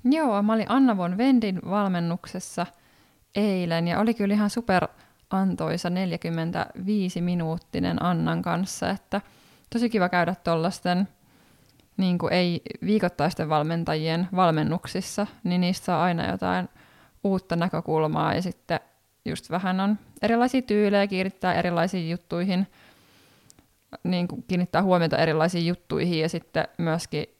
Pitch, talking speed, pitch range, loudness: 180 Hz, 120 wpm, 170-200 Hz, -25 LUFS